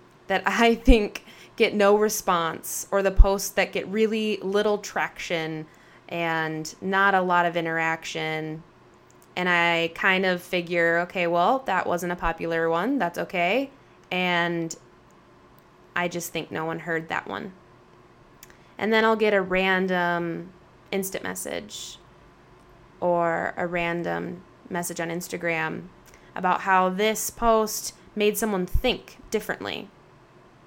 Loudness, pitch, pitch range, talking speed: -25 LUFS, 175 Hz, 170-200 Hz, 125 wpm